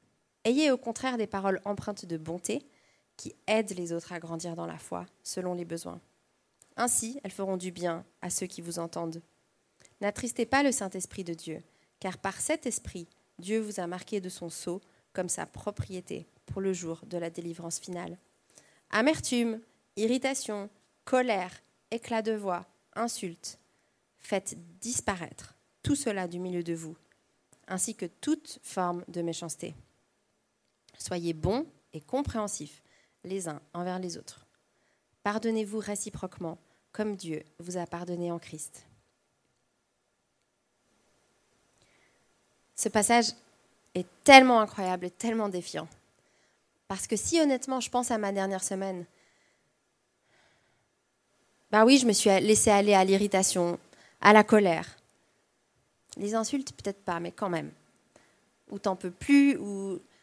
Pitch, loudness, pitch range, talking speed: 190 Hz, -29 LUFS, 175-220 Hz, 140 wpm